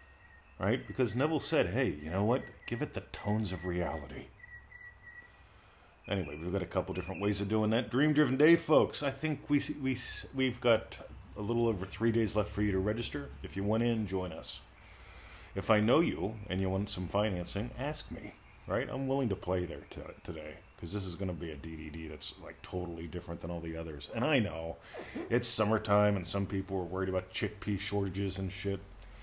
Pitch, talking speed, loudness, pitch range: 100 Hz, 200 wpm, -33 LUFS, 90-115 Hz